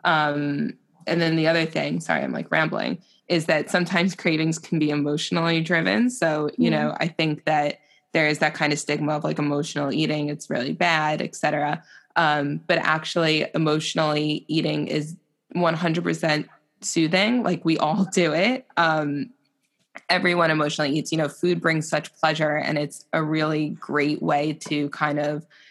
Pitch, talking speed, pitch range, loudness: 155 Hz, 165 wpm, 150-165 Hz, -23 LUFS